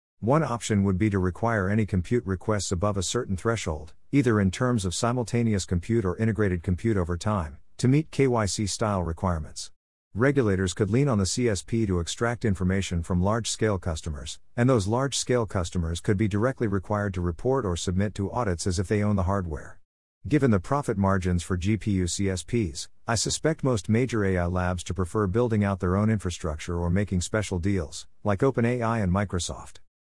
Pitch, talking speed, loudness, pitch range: 100 Hz, 175 wpm, -26 LUFS, 90-115 Hz